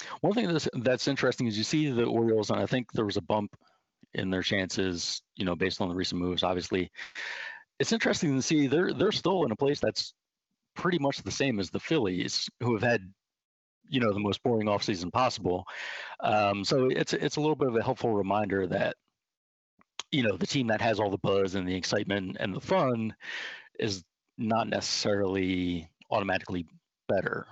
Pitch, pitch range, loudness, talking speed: 105 Hz, 95-130 Hz, -29 LUFS, 190 wpm